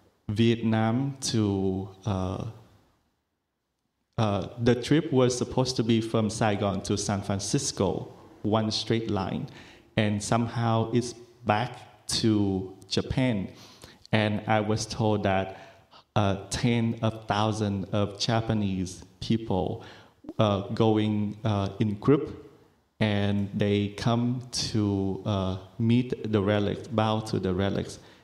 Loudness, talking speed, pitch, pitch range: -27 LUFS, 115 wpm, 110 Hz, 100-115 Hz